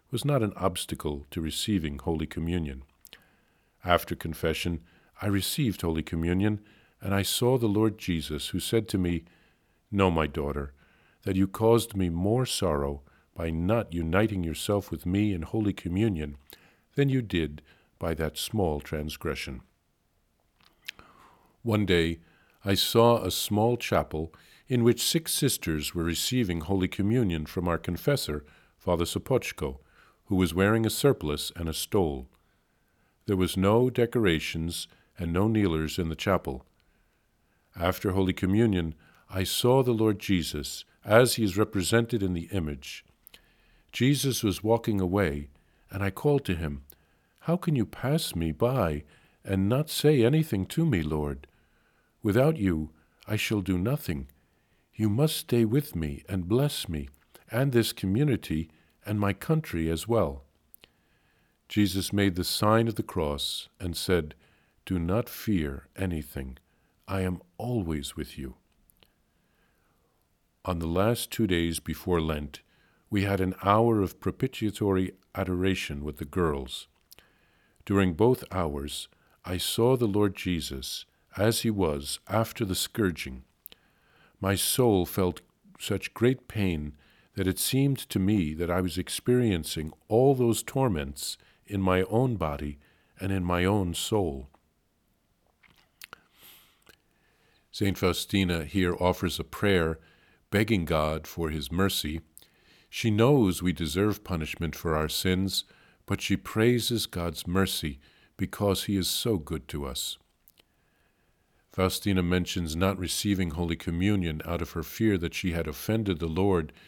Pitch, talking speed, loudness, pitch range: 95 Hz, 140 wpm, -28 LUFS, 80-105 Hz